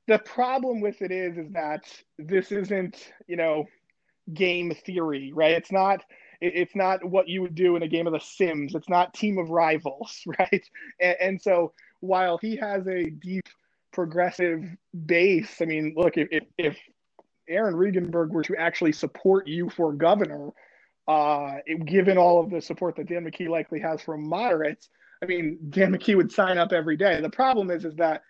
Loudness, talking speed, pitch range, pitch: -25 LUFS, 180 wpm, 160-190 Hz, 175 Hz